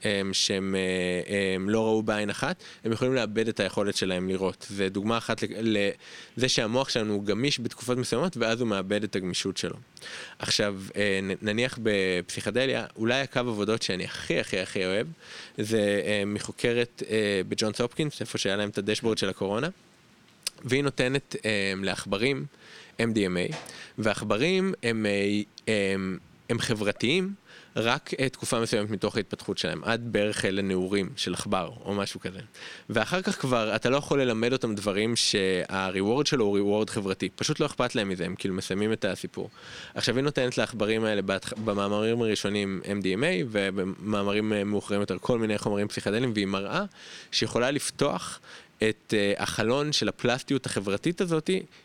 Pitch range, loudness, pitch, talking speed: 100-125 Hz, -28 LUFS, 105 Hz, 145 wpm